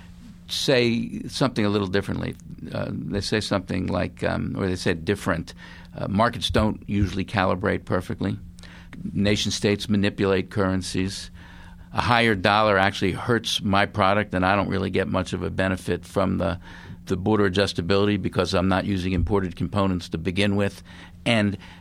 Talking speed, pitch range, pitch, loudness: 160 wpm, 90-100 Hz, 95 Hz, -24 LUFS